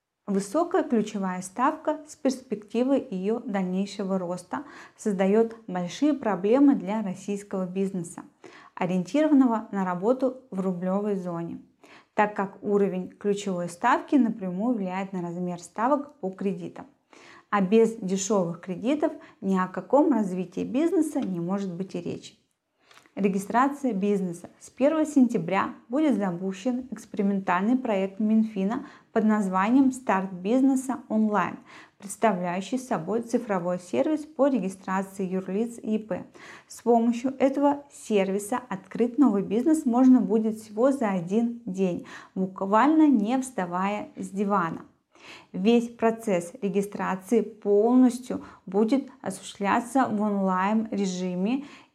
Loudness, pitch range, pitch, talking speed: -26 LUFS, 190-255 Hz, 215 Hz, 110 wpm